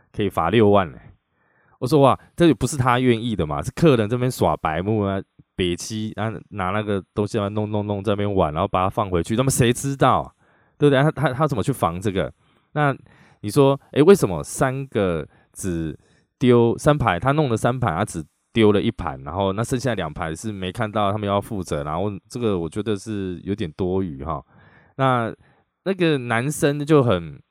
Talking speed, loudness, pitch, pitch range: 280 characters per minute, -21 LUFS, 110 Hz, 95-130 Hz